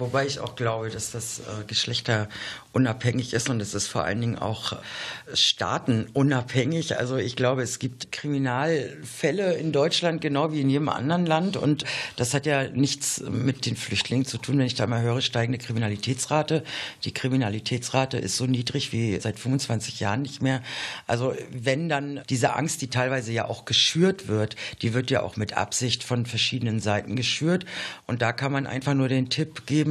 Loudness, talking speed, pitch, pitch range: -26 LUFS, 180 wpm, 125 Hz, 115-140 Hz